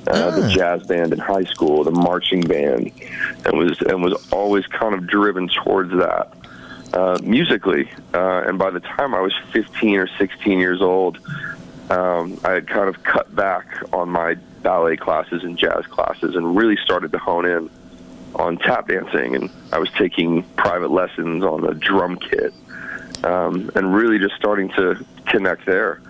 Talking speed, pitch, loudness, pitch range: 170 wpm, 90 Hz, -19 LUFS, 85-95 Hz